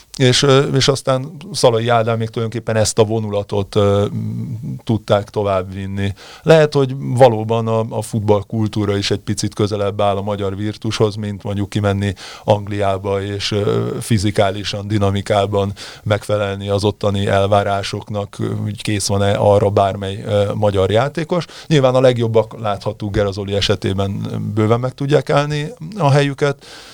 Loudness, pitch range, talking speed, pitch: -17 LUFS, 100-115 Hz, 135 wpm, 105 Hz